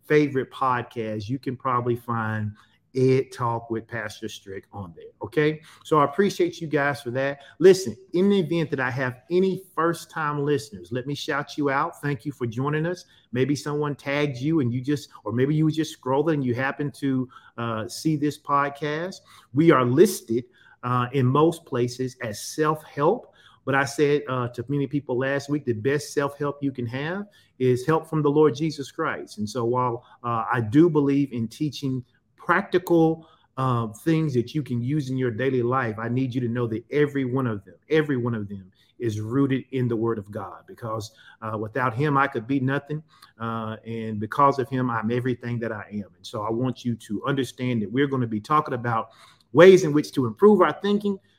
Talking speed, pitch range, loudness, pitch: 205 wpm, 120-150 Hz, -24 LUFS, 135 Hz